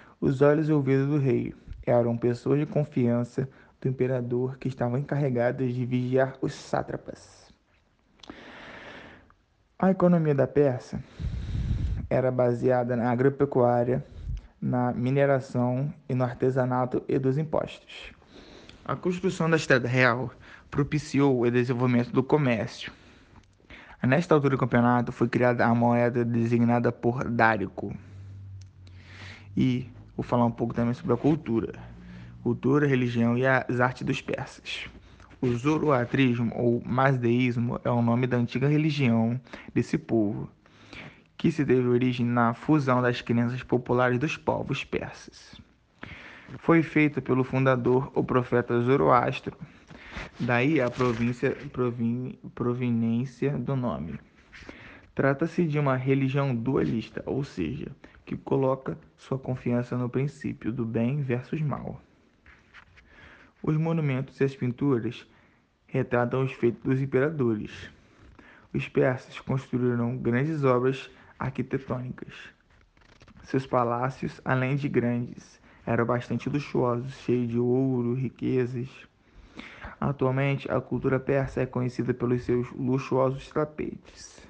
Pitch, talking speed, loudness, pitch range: 125 Hz, 115 wpm, -26 LUFS, 120-135 Hz